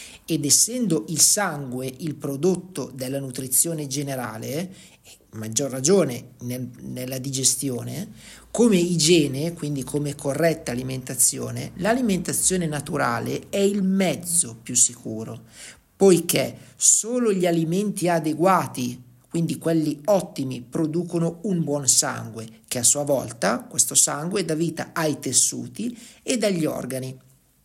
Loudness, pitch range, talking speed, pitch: -22 LUFS, 130-175 Hz, 115 wpm, 145 Hz